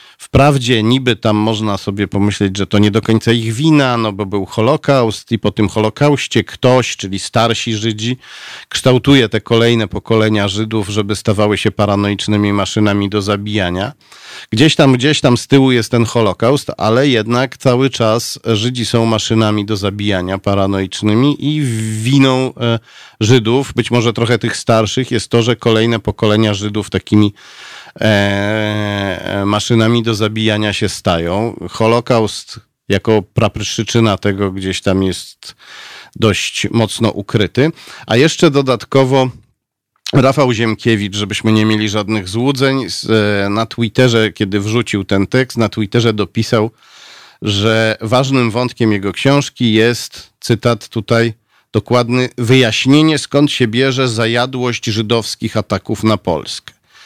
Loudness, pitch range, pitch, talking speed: -14 LUFS, 105-125 Hz, 110 Hz, 135 wpm